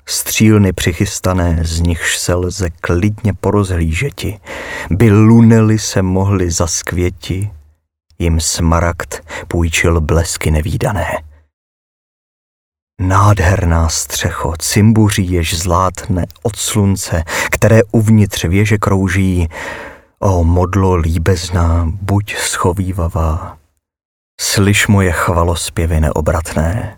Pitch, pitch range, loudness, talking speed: 90 Hz, 85-100 Hz, -14 LUFS, 85 wpm